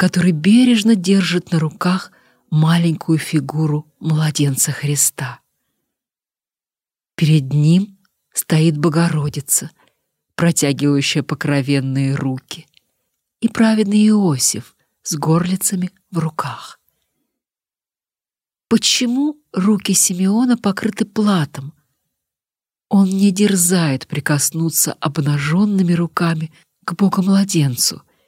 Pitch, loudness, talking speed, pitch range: 170 Hz, -16 LUFS, 75 wpm, 150-195 Hz